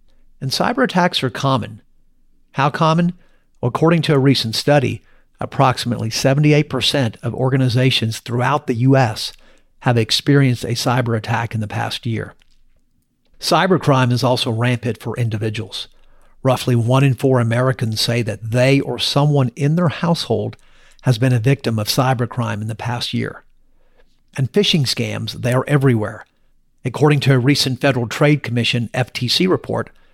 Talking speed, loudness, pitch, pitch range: 145 wpm, -17 LUFS, 125 Hz, 115-140 Hz